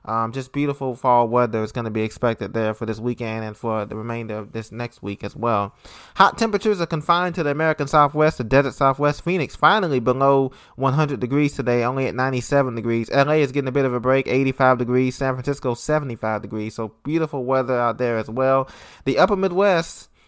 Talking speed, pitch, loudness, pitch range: 205 wpm, 130 Hz, -21 LUFS, 115-145 Hz